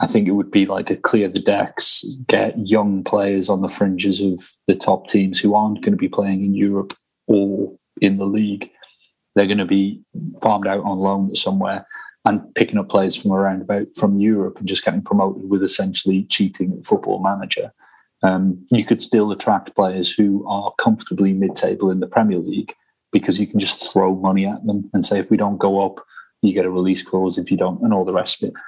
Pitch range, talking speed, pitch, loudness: 95-100 Hz, 215 wpm, 100 Hz, -18 LUFS